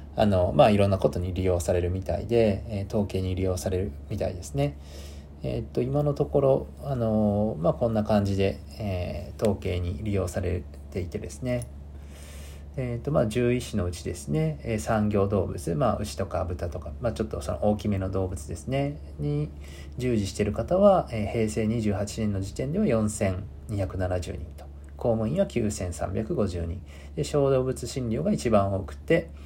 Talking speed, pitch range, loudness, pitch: 310 characters per minute, 85-110 Hz, -27 LUFS, 95 Hz